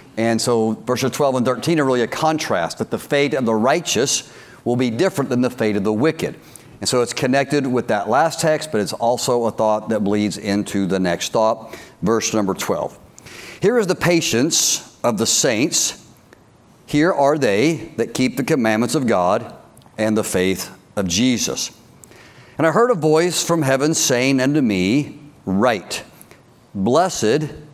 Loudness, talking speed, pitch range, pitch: -18 LUFS, 175 wpm, 110-150 Hz, 125 Hz